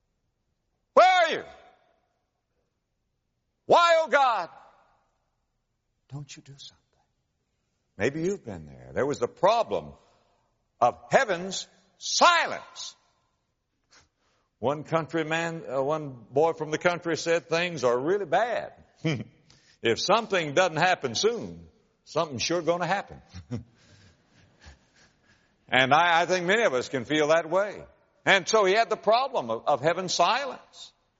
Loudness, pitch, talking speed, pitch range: -25 LUFS, 165 Hz, 120 wpm, 145-195 Hz